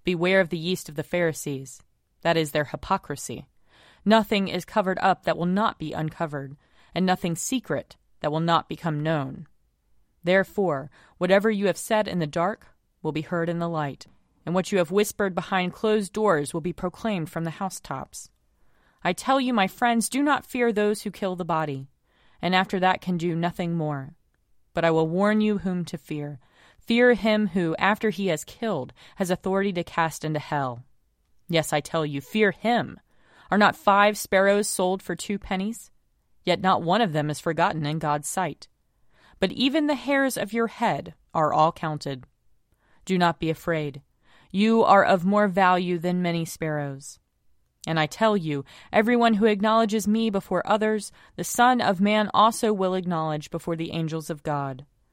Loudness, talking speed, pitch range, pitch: -24 LUFS, 180 wpm, 155-205 Hz, 180 Hz